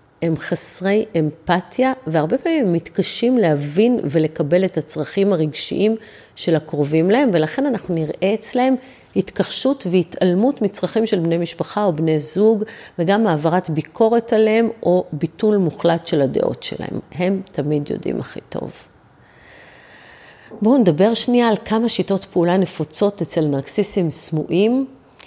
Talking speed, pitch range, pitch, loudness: 125 wpm, 160-220 Hz, 185 Hz, -19 LUFS